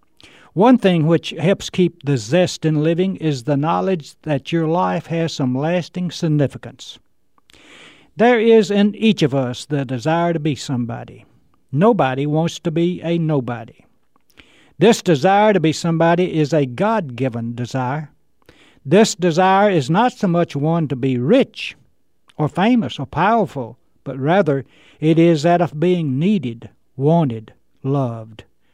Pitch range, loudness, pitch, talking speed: 135-180 Hz, -17 LUFS, 160 Hz, 145 wpm